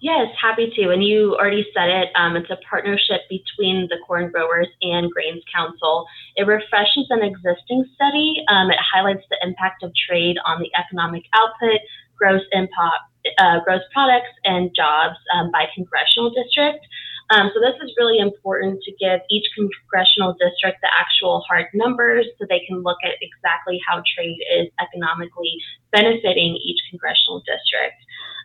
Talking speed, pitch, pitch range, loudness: 160 wpm, 190 Hz, 175-225 Hz, -18 LUFS